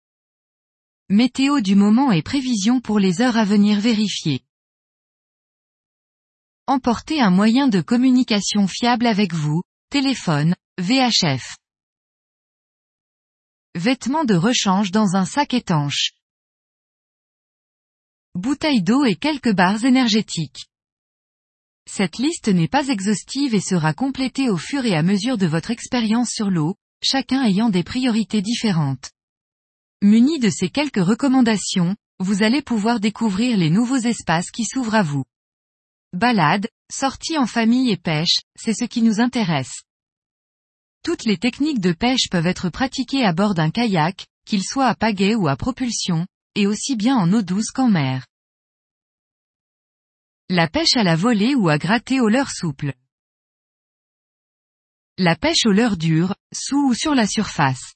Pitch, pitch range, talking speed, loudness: 215 Hz, 180-250 Hz, 135 wpm, -19 LUFS